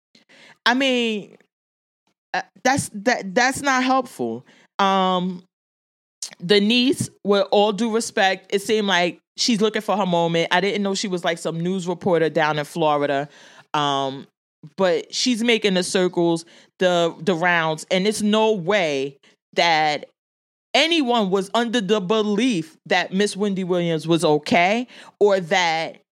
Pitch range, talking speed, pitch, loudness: 165-220 Hz, 140 wpm, 190 Hz, -20 LUFS